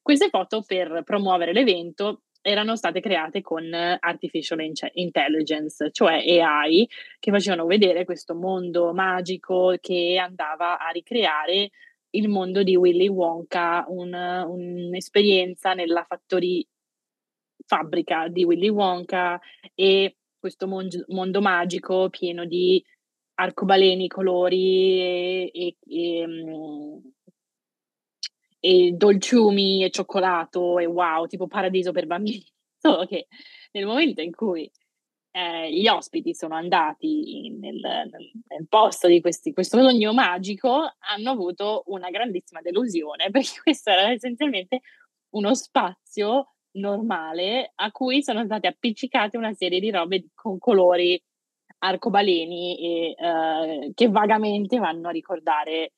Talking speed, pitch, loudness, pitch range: 115 wpm, 185 Hz, -22 LUFS, 175-215 Hz